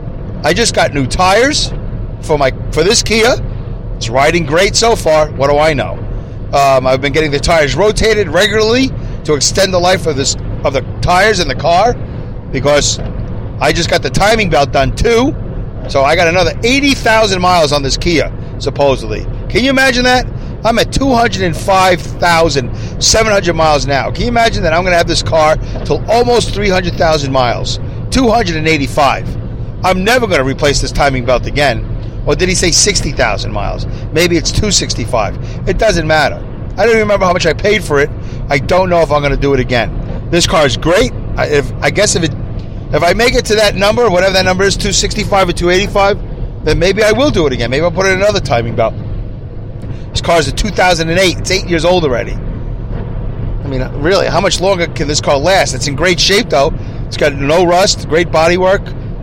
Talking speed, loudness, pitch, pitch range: 205 wpm, -11 LUFS, 145 Hz, 120-185 Hz